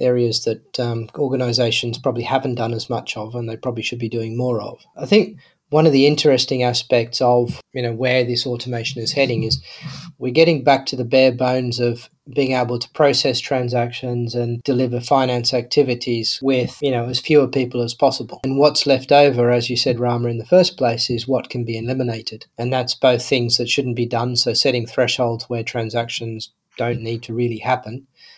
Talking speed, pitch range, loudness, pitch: 200 wpm, 120-135 Hz, -19 LUFS, 125 Hz